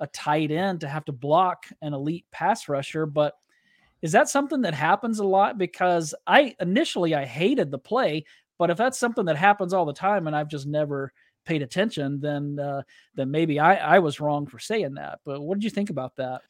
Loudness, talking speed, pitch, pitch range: -24 LUFS, 215 wpm, 155 Hz, 145-195 Hz